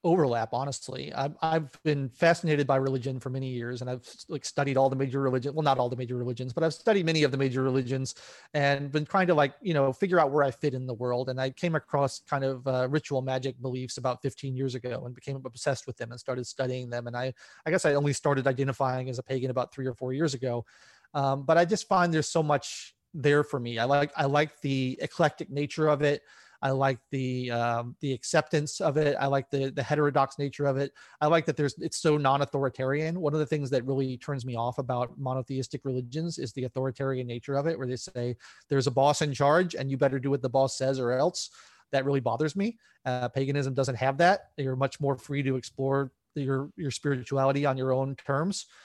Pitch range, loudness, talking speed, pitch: 130-145 Hz, -29 LUFS, 230 wpm, 135 Hz